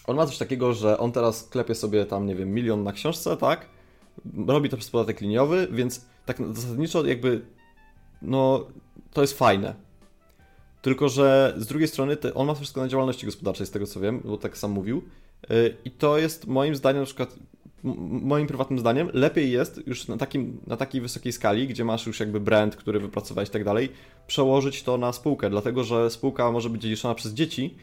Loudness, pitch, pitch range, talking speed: -25 LUFS, 120 Hz, 105-135 Hz, 190 wpm